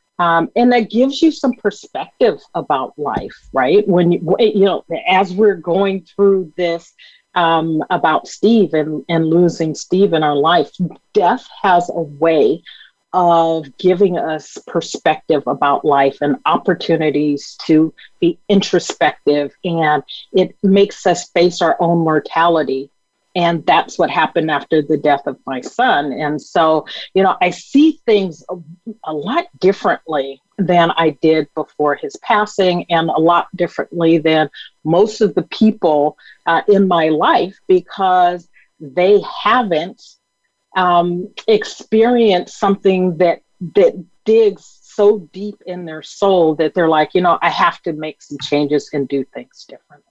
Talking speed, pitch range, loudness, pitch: 145 wpm, 155-195 Hz, -15 LUFS, 175 Hz